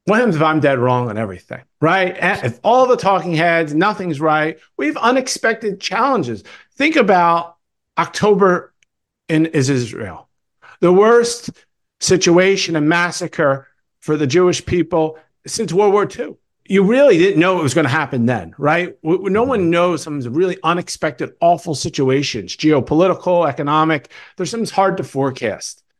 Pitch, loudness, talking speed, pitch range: 170 Hz, -16 LUFS, 150 wpm, 155-195 Hz